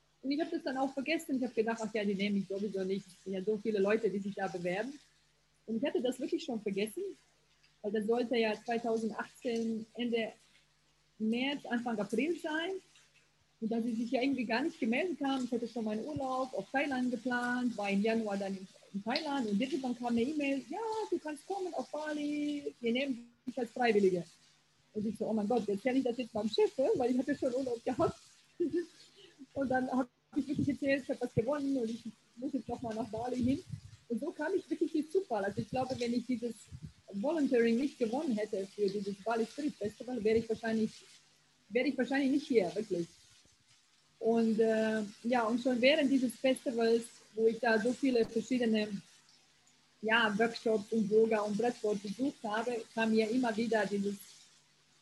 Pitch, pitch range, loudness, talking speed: 240 Hz, 220-270 Hz, -34 LUFS, 195 wpm